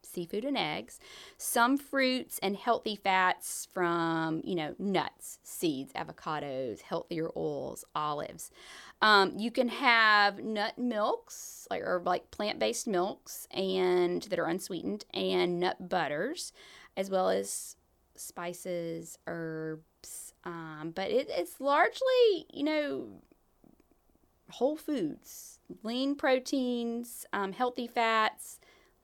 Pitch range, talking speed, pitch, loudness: 175-255 Hz, 110 wpm, 200 Hz, -31 LUFS